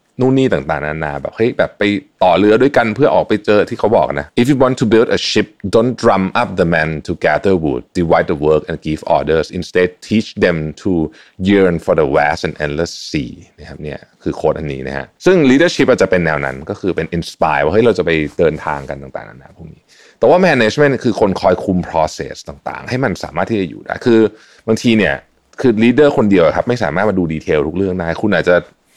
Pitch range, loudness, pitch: 75-110 Hz, -14 LUFS, 90 Hz